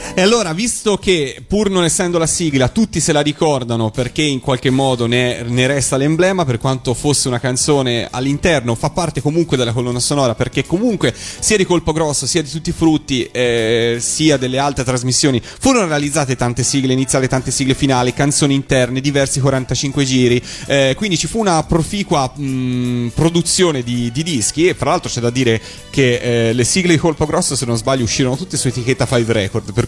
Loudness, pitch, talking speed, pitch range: -15 LUFS, 135 Hz, 195 wpm, 125-160 Hz